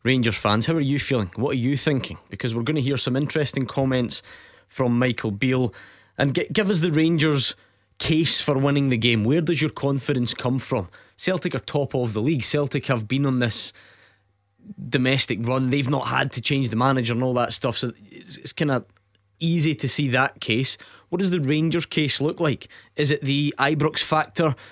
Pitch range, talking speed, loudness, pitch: 120-150 Hz, 205 wpm, -23 LUFS, 135 Hz